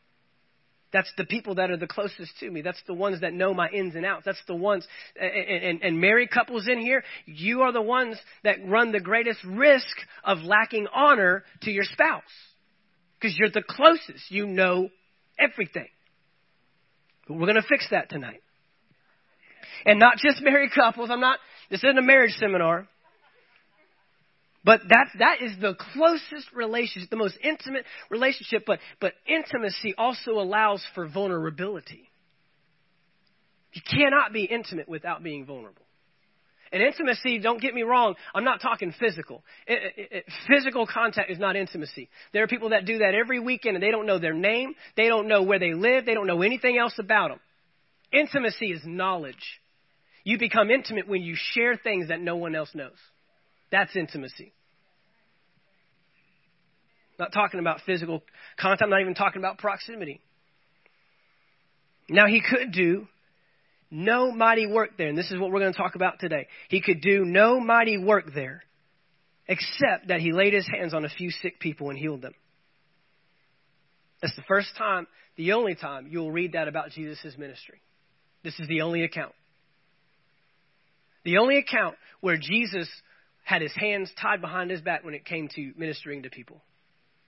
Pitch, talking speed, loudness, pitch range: 195 Hz, 165 wpm, -24 LUFS, 170-225 Hz